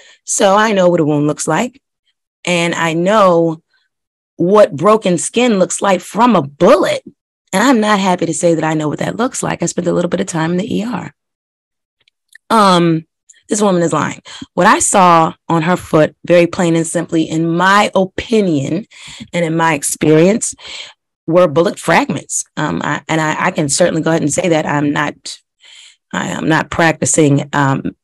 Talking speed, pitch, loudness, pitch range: 180 wpm, 170 Hz, -13 LUFS, 160-195 Hz